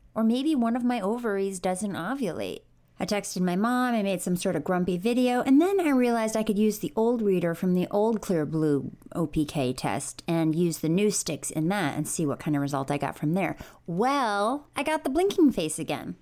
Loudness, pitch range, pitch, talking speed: -26 LUFS, 160-230 Hz, 190 Hz, 220 wpm